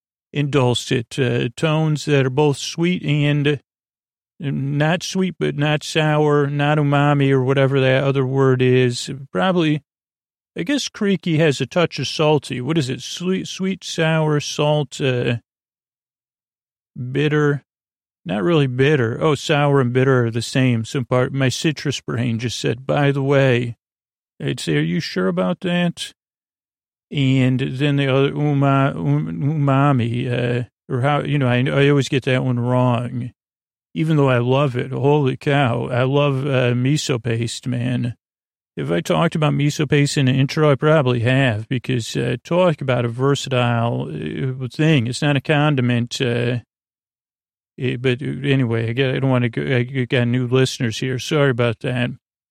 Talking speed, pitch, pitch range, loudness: 160 wpm, 135 Hz, 125-150 Hz, -19 LUFS